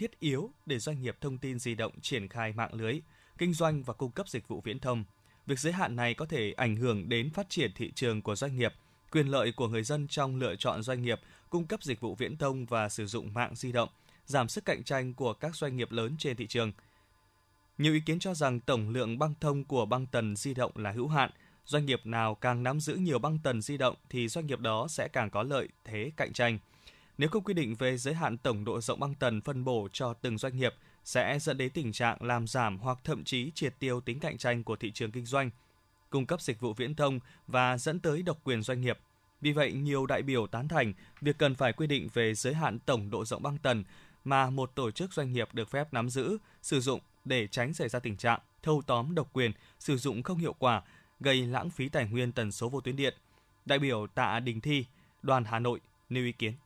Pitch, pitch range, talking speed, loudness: 125 Hz, 115-145 Hz, 245 wpm, -33 LUFS